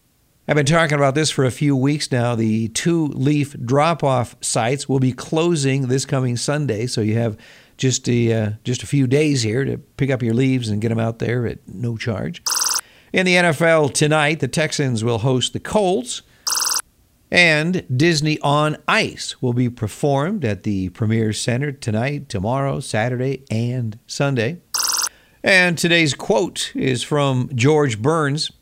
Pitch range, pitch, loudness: 120-150 Hz, 135 Hz, -19 LUFS